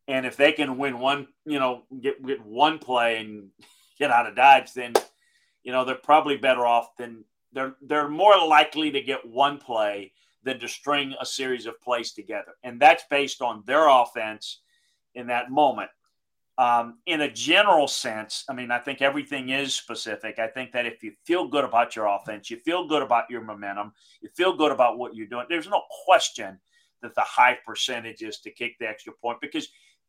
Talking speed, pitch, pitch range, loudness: 195 wpm, 130 Hz, 120-150 Hz, -23 LUFS